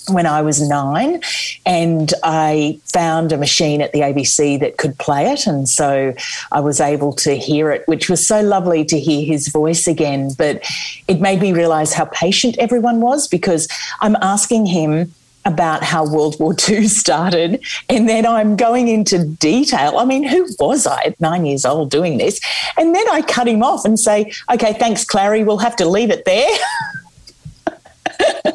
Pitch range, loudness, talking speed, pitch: 155-220 Hz, -15 LUFS, 180 wpm, 175 Hz